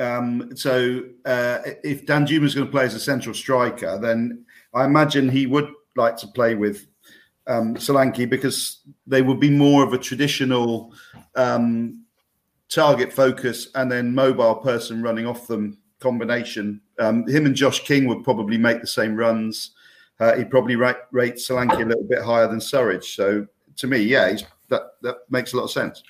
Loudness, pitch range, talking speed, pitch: -21 LUFS, 115-135 Hz, 180 wpm, 125 Hz